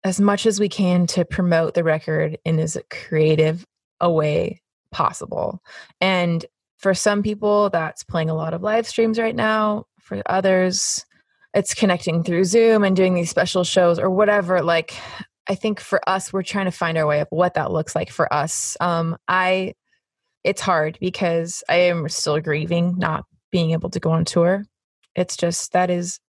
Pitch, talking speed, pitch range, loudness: 180 Hz, 180 wpm, 165-195 Hz, -20 LUFS